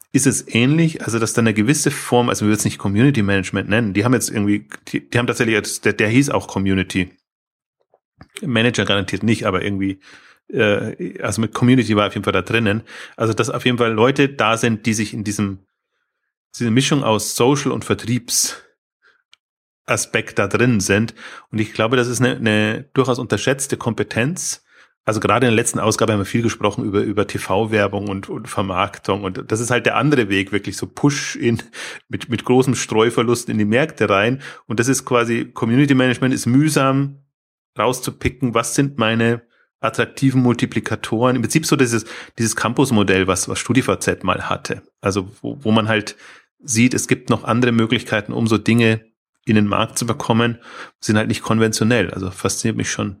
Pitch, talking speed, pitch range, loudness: 115 Hz, 185 wpm, 105-125 Hz, -18 LUFS